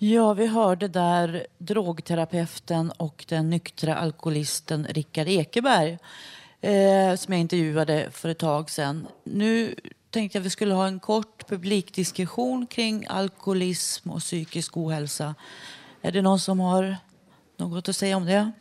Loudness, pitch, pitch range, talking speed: -25 LUFS, 180 Hz, 160-200 Hz, 140 wpm